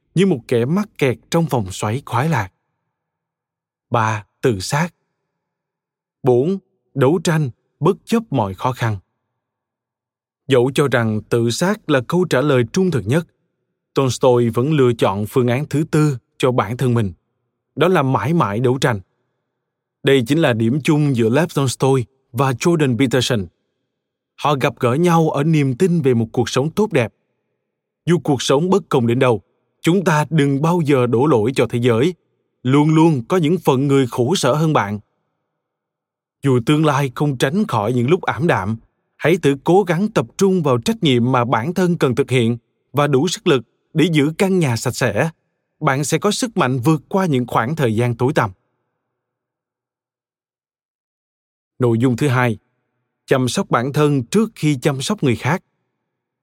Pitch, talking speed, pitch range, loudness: 135 Hz, 175 wpm, 125-160 Hz, -17 LUFS